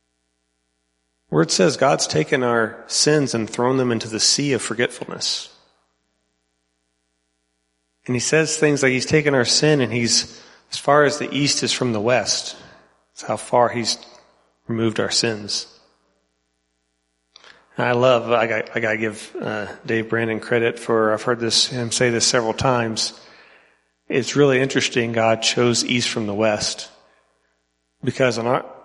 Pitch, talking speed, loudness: 115 Hz, 155 wpm, -19 LUFS